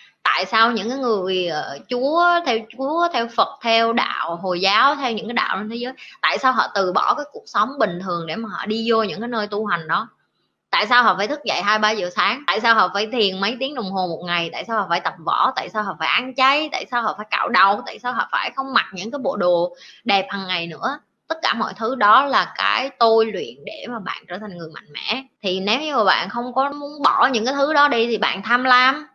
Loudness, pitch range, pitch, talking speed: -19 LUFS, 195-265 Hz, 225 Hz, 270 wpm